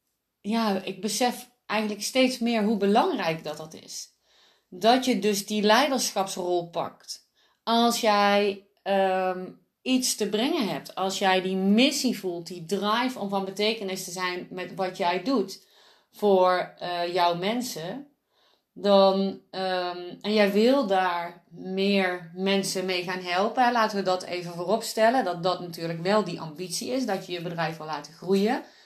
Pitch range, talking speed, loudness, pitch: 180-220 Hz, 155 wpm, -25 LUFS, 195 Hz